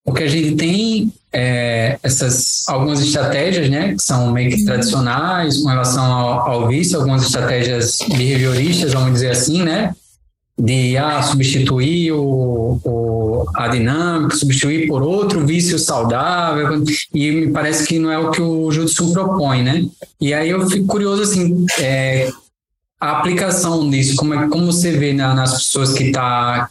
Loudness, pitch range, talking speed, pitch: -16 LUFS, 125-160 Hz, 155 wpm, 145 Hz